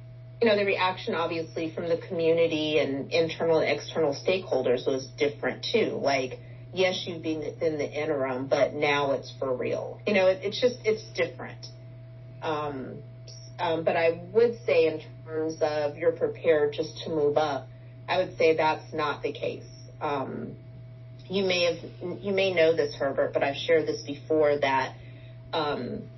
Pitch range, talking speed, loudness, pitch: 125-165 Hz, 165 wpm, -27 LUFS, 155 Hz